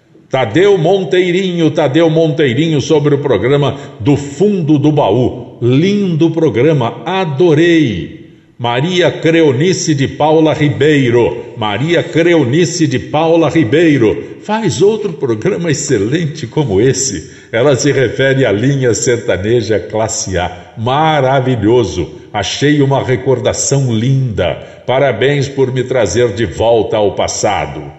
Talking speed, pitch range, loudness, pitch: 110 wpm, 130-165 Hz, -12 LUFS, 145 Hz